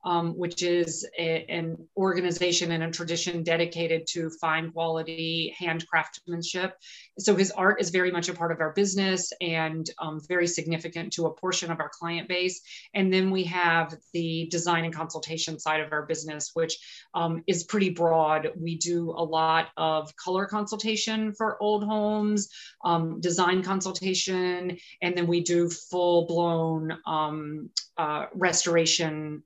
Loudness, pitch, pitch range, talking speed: -27 LUFS, 170 Hz, 165-185 Hz, 155 wpm